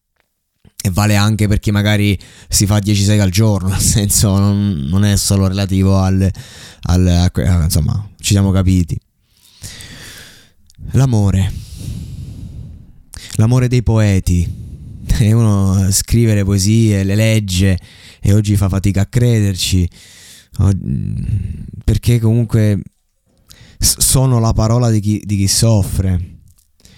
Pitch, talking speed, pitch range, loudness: 100 Hz, 120 wpm, 95-110 Hz, -14 LUFS